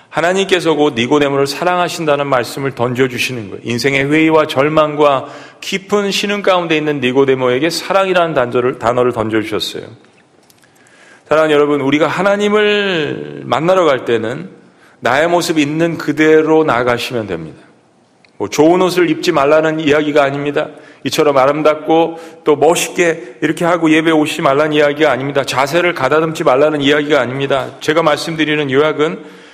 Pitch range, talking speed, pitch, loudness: 140-165 Hz, 360 characters per minute, 150 Hz, -13 LUFS